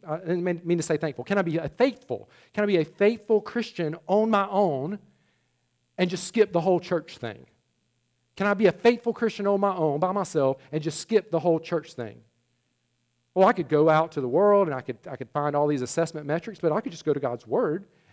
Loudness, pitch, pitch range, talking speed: -25 LUFS, 170 Hz, 150-200 Hz, 230 wpm